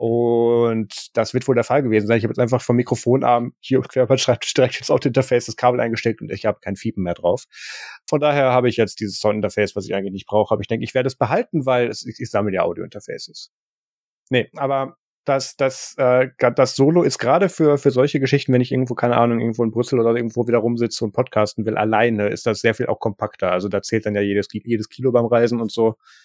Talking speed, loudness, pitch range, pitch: 240 wpm, -19 LUFS, 110-130 Hz, 120 Hz